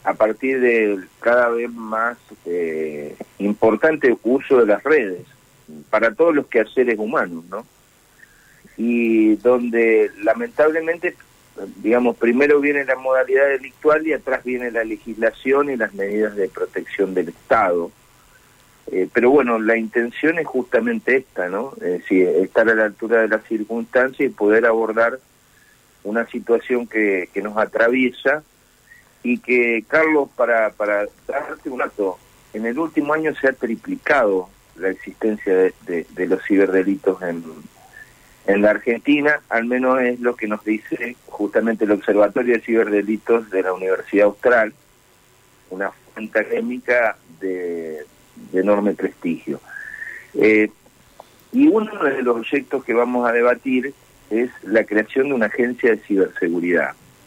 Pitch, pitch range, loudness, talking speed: 115 Hz, 105-130 Hz, -19 LUFS, 140 wpm